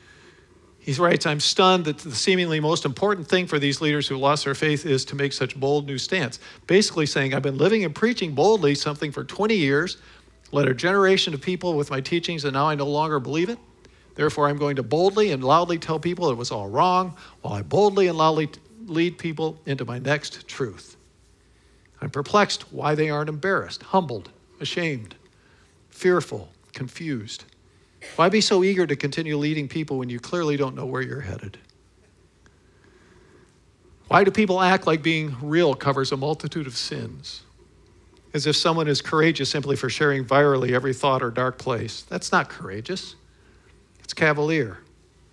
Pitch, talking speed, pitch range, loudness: 145 Hz, 175 wpm, 130-165 Hz, -23 LUFS